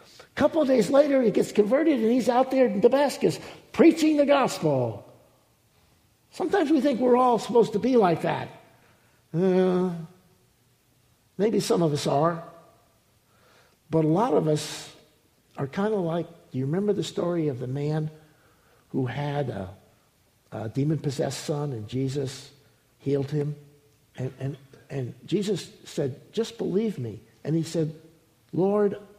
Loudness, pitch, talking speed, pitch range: -25 LUFS, 160 Hz, 145 wpm, 135-205 Hz